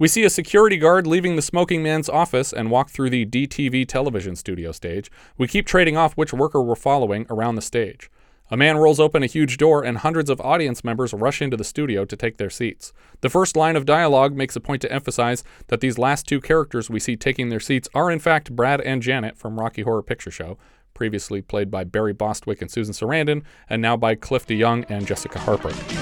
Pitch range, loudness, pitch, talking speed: 110-155 Hz, -20 LUFS, 130 Hz, 220 wpm